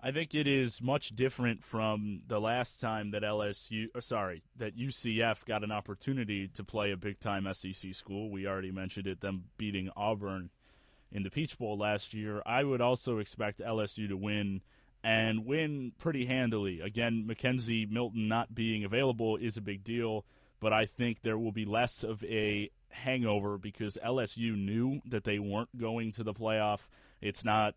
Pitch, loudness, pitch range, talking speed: 110 Hz, -35 LUFS, 105-120 Hz, 175 wpm